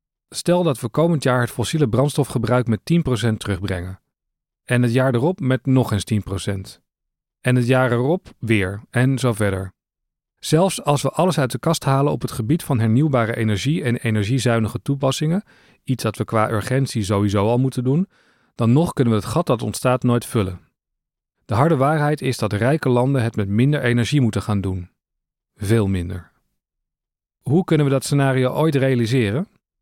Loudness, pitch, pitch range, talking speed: -20 LUFS, 125 Hz, 110-140 Hz, 175 wpm